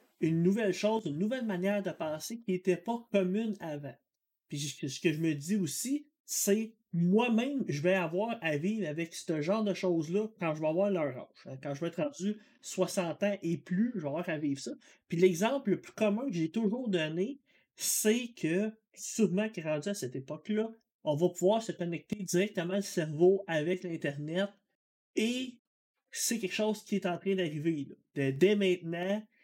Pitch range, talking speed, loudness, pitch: 165-215 Hz, 190 wpm, -32 LUFS, 190 Hz